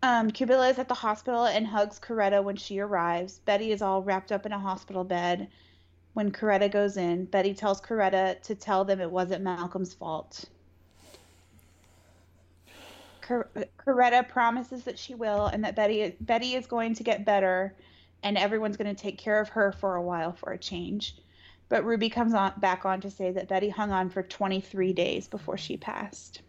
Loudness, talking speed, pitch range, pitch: -28 LUFS, 185 wpm, 180-215 Hz, 195 Hz